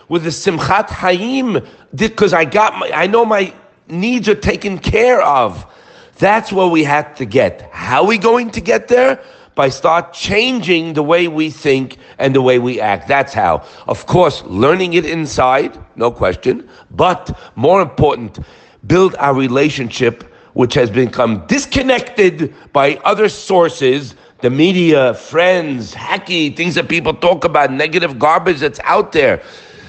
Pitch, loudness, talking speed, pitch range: 170 Hz, -14 LUFS, 155 wpm, 145-210 Hz